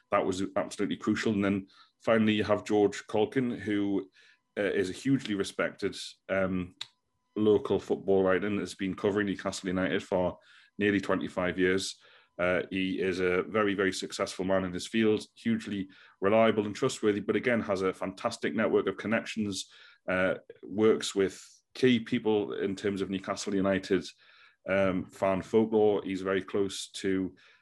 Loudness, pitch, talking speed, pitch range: -30 LUFS, 100 Hz, 155 wpm, 95-105 Hz